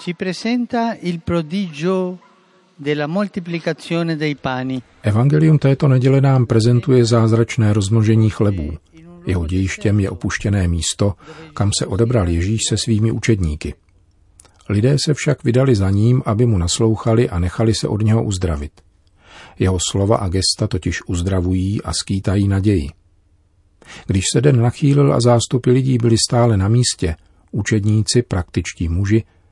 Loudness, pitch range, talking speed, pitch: -17 LUFS, 95-135 Hz, 120 wpm, 115 Hz